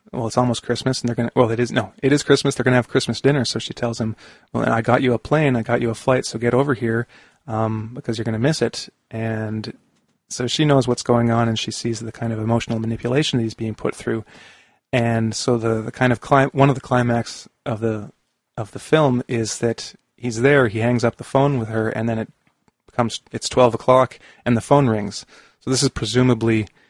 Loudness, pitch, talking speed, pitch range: -20 LUFS, 120 Hz, 245 wpm, 115-130 Hz